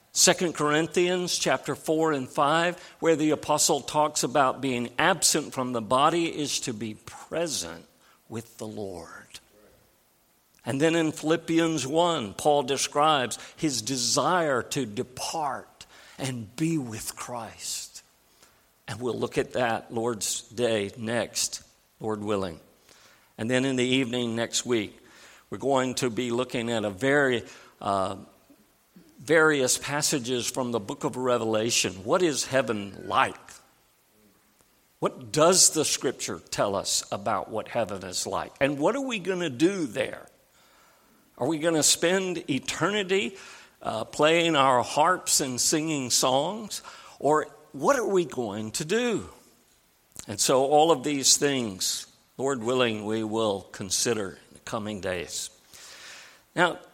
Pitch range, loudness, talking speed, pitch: 115-160 Hz, -26 LUFS, 135 wpm, 135 Hz